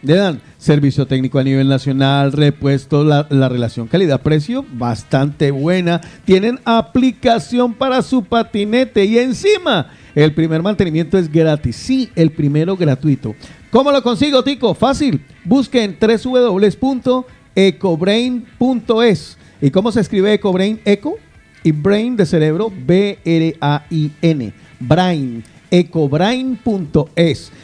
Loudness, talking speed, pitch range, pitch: -15 LUFS, 120 wpm, 150-230 Hz, 180 Hz